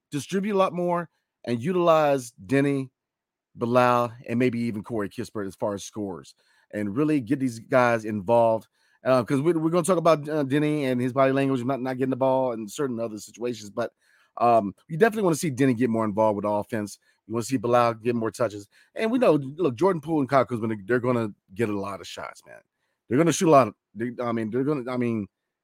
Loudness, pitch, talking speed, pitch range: -25 LUFS, 125 Hz, 230 wpm, 115-145 Hz